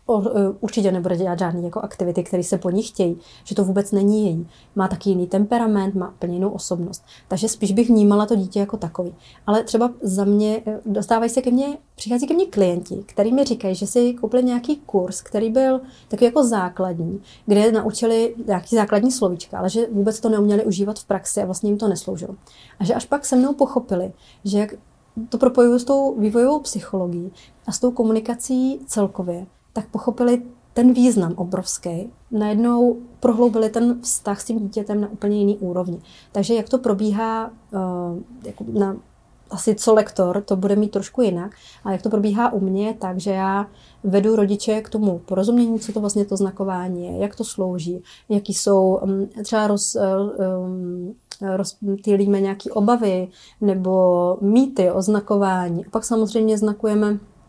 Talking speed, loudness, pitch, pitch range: 170 wpm, -20 LUFS, 205 Hz, 190-225 Hz